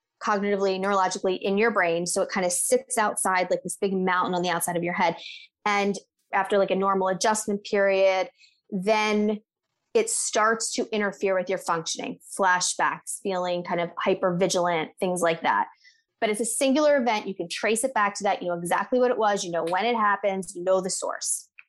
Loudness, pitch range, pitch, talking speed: -25 LUFS, 180-220 Hz, 195 Hz, 195 wpm